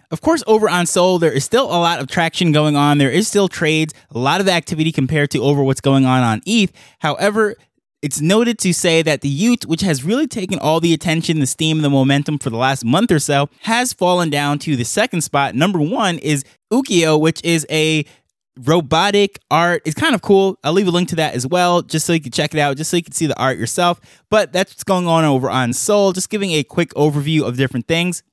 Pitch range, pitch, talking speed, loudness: 145-180 Hz, 160 Hz, 240 wpm, -16 LUFS